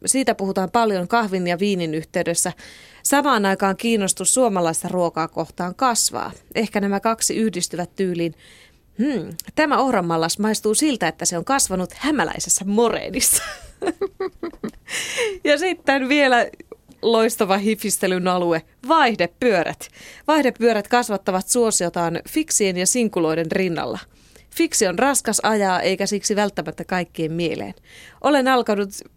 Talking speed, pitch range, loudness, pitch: 115 wpm, 180-255 Hz, -20 LUFS, 205 Hz